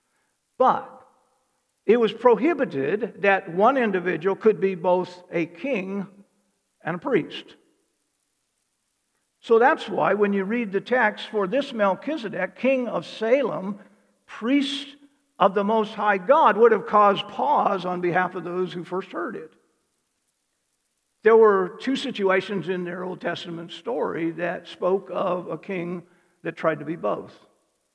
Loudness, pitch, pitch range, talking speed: -23 LUFS, 195 Hz, 180-225 Hz, 140 wpm